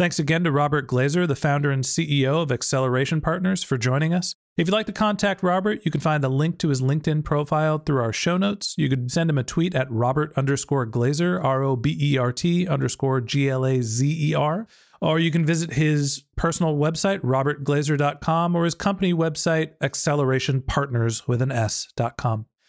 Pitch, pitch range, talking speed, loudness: 150 Hz, 135-165 Hz, 170 wpm, -23 LUFS